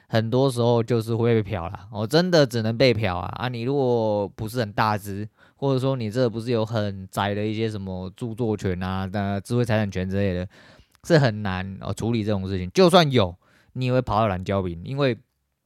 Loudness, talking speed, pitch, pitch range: -23 LUFS, 305 characters per minute, 110 Hz, 100-125 Hz